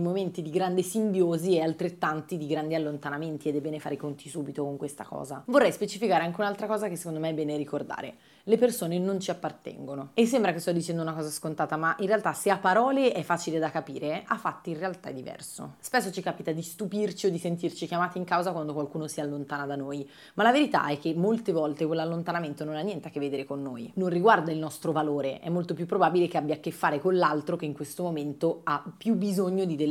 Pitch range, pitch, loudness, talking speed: 150-185 Hz, 165 Hz, -29 LUFS, 235 wpm